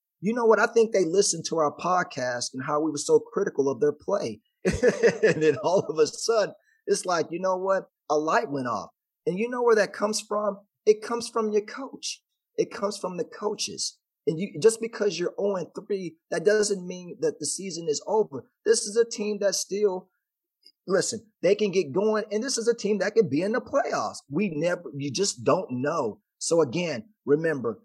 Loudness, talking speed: -26 LUFS, 210 wpm